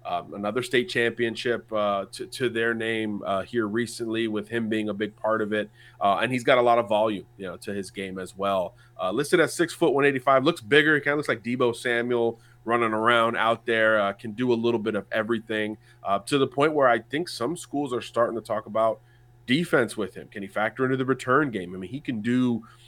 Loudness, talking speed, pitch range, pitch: -25 LUFS, 245 wpm, 105-125 Hz, 115 Hz